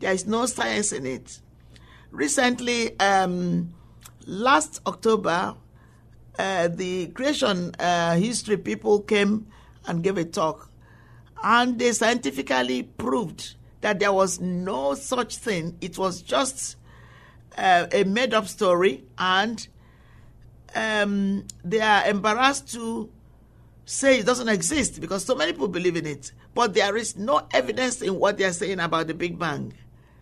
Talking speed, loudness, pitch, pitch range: 140 wpm, -24 LUFS, 195 Hz, 170-225 Hz